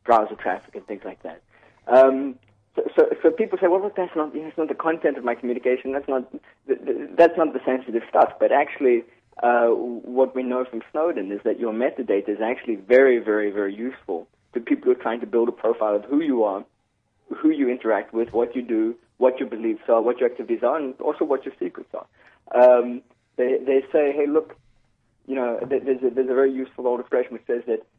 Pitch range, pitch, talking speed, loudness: 120-170 Hz, 130 Hz, 220 wpm, -22 LUFS